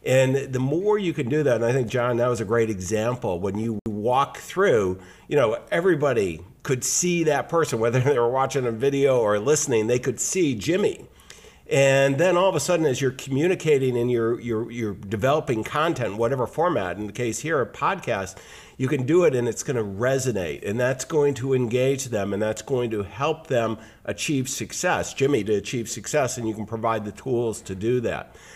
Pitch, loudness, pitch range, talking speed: 125 Hz, -23 LUFS, 110-135 Hz, 205 wpm